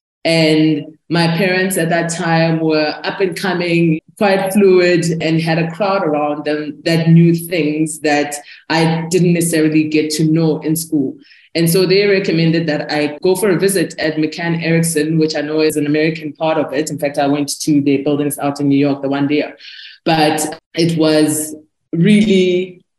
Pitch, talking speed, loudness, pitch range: 160 Hz, 185 wpm, -15 LUFS, 150-170 Hz